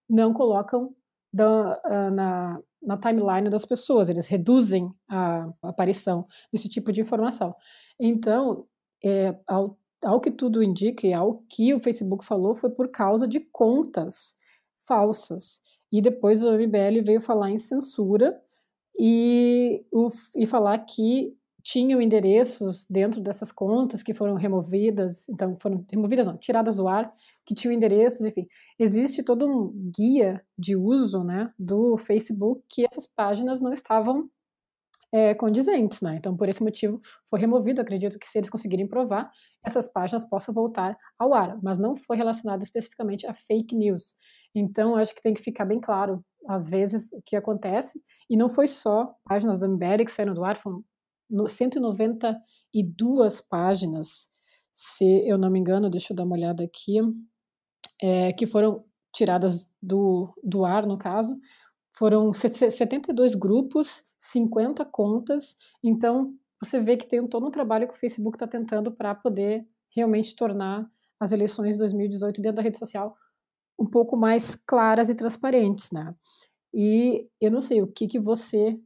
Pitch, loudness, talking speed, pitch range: 220 Hz, -24 LUFS, 155 wpm, 200-235 Hz